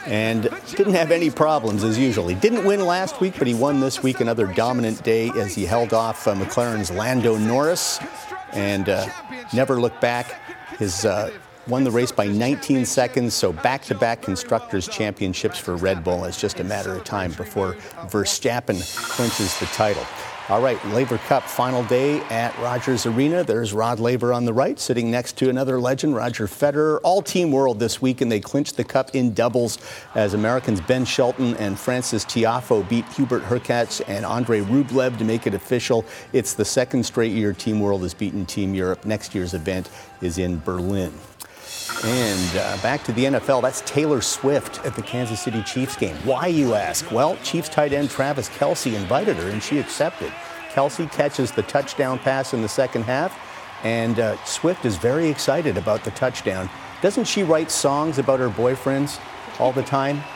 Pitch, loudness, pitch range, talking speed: 120 Hz, -22 LUFS, 110-135 Hz, 185 wpm